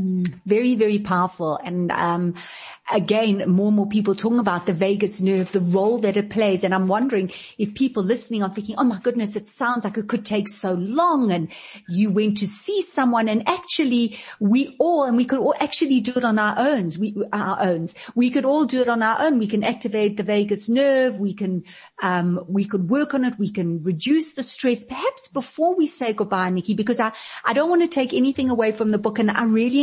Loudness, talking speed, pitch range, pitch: -21 LUFS, 220 wpm, 195-250 Hz, 215 Hz